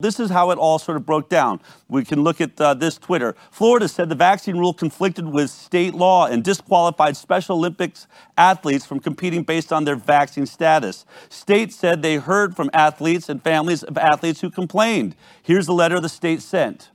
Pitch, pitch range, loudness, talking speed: 165 Hz, 155-180 Hz, -19 LUFS, 195 wpm